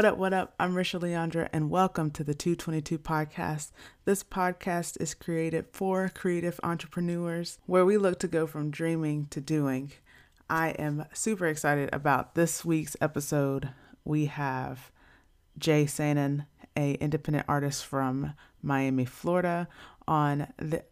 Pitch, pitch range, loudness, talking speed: 155 Hz, 145-175 Hz, -30 LUFS, 140 wpm